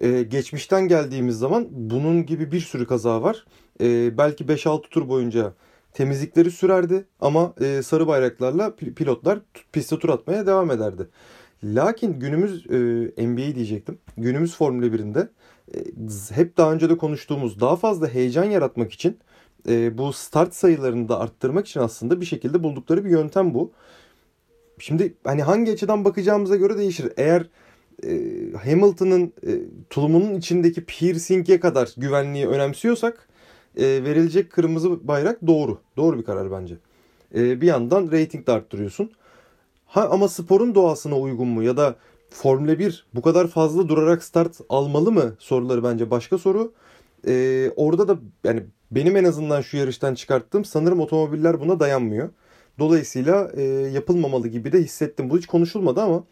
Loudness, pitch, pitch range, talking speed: -21 LUFS, 160 Hz, 130-180 Hz, 140 wpm